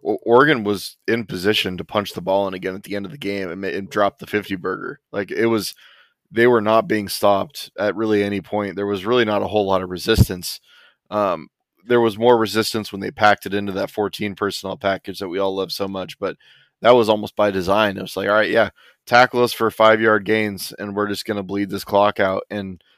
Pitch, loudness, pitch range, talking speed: 105 Hz, -20 LUFS, 100-110 Hz, 240 wpm